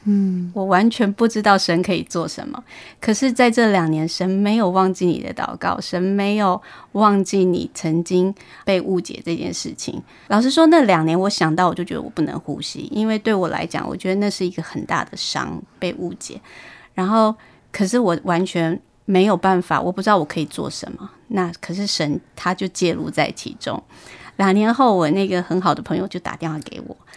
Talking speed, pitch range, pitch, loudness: 285 characters per minute, 175-210 Hz, 190 Hz, -19 LUFS